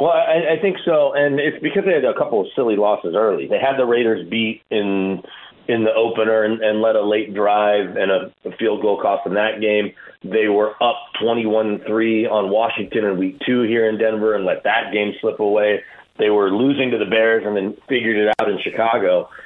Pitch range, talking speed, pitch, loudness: 105-135 Hz, 225 wpm, 110 Hz, -18 LUFS